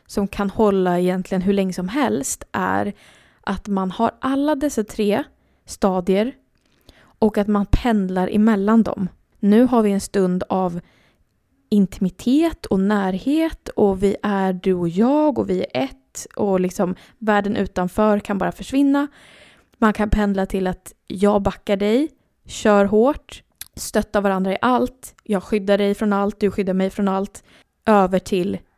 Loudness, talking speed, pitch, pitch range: -20 LUFS, 155 wpm, 200 Hz, 190-220 Hz